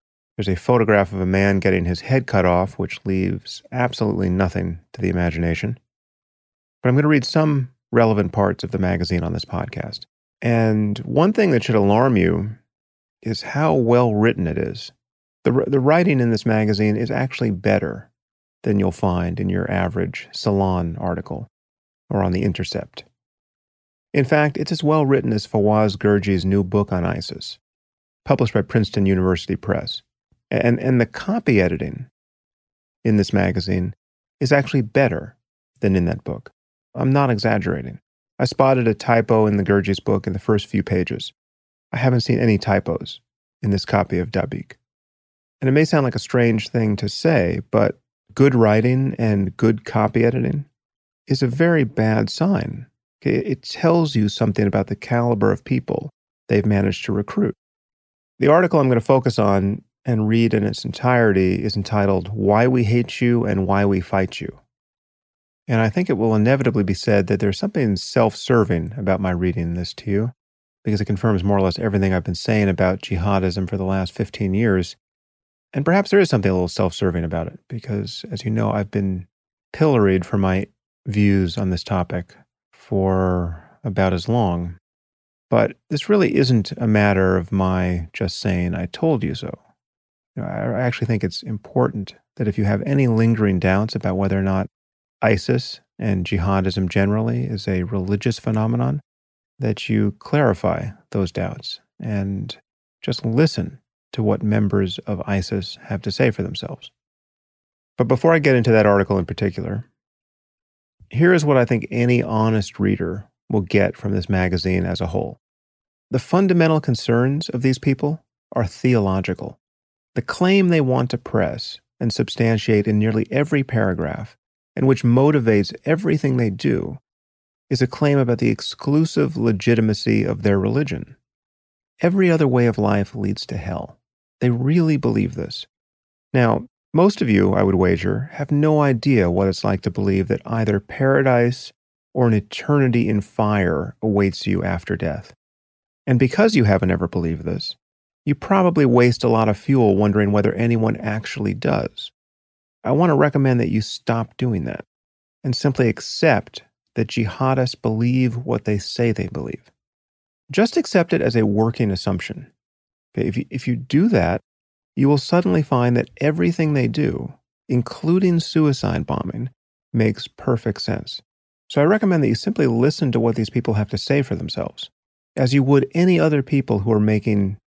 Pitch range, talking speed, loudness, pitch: 100-130 Hz, 165 wpm, -20 LUFS, 110 Hz